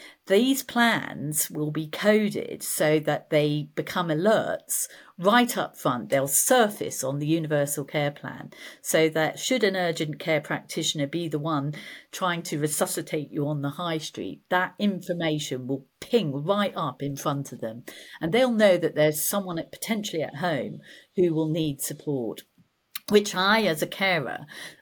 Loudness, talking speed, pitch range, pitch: -25 LUFS, 160 wpm, 150-200 Hz, 160 Hz